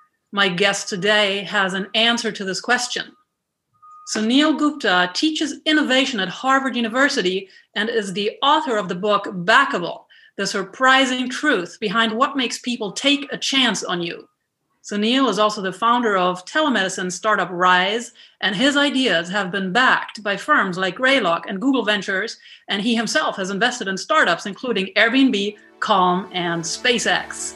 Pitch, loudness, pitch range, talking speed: 220 Hz, -19 LUFS, 195-265 Hz, 150 wpm